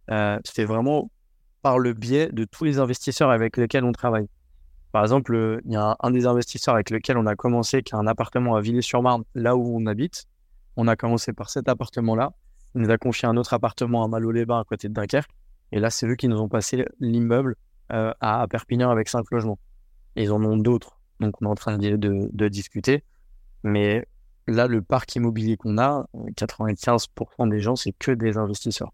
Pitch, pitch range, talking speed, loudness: 115 Hz, 110-125 Hz, 210 wpm, -23 LUFS